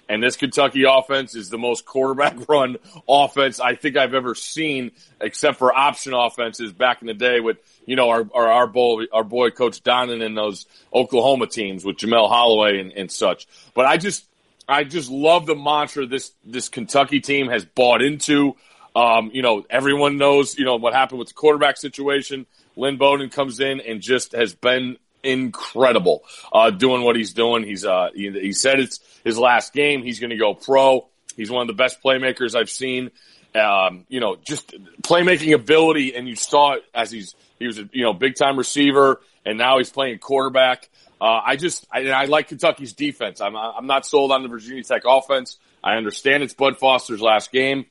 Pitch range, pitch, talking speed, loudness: 120-140 Hz, 130 Hz, 195 wpm, -19 LUFS